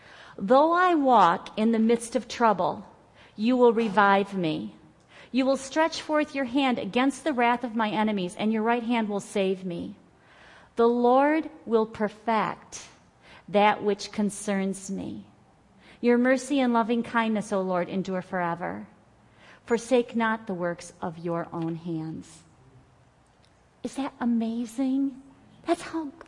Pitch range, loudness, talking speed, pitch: 195-255 Hz, -26 LUFS, 140 wpm, 225 Hz